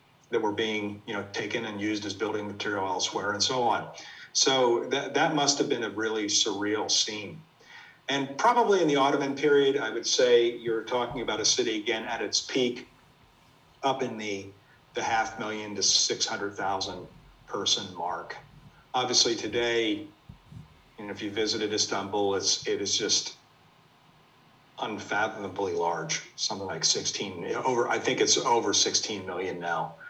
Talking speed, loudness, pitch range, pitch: 155 wpm, -27 LUFS, 105-140 Hz, 120 Hz